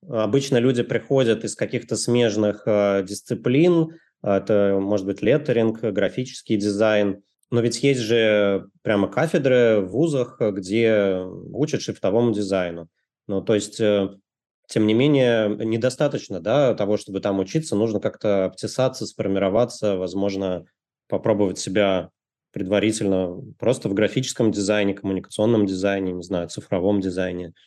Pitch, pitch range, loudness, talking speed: 105 Hz, 100-120 Hz, -22 LUFS, 120 wpm